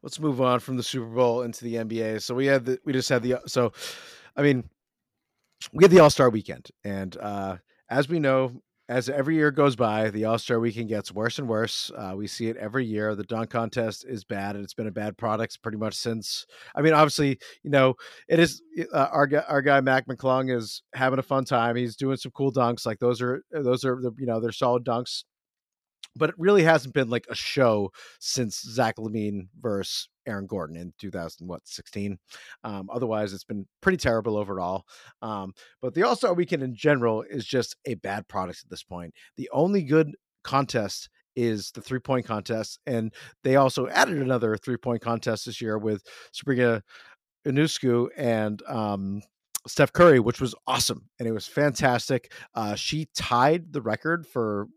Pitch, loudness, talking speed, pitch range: 120 Hz, -25 LUFS, 195 wpm, 110-135 Hz